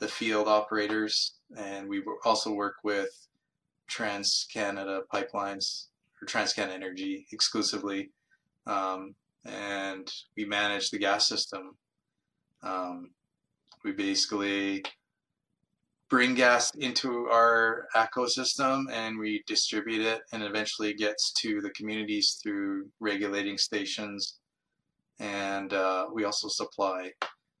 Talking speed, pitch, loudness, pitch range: 105 wpm, 105 Hz, -29 LUFS, 100-115 Hz